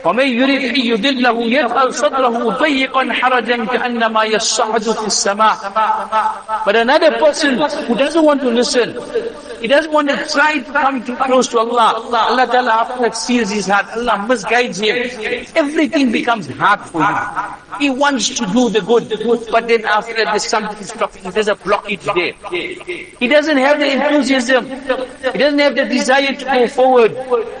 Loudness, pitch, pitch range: -15 LUFS, 250 Hz, 225-280 Hz